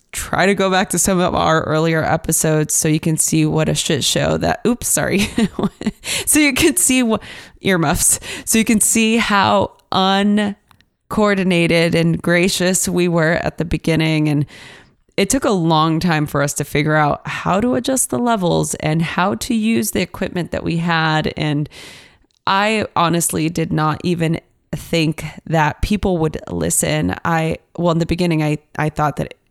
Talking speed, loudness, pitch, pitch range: 175 wpm, -17 LUFS, 170 Hz, 155-195 Hz